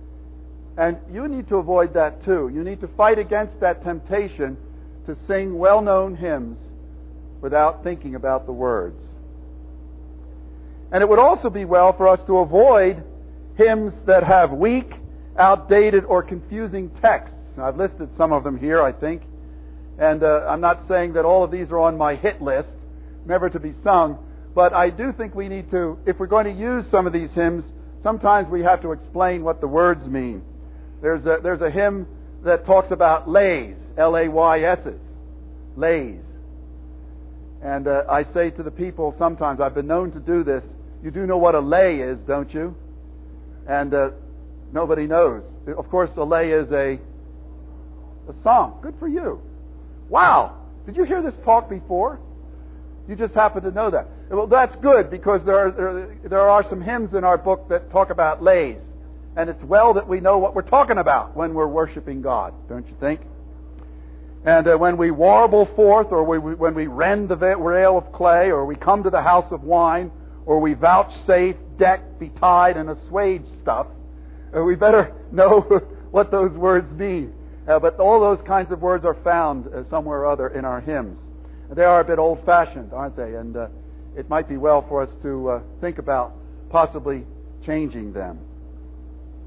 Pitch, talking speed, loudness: 165 Hz, 180 wpm, -19 LUFS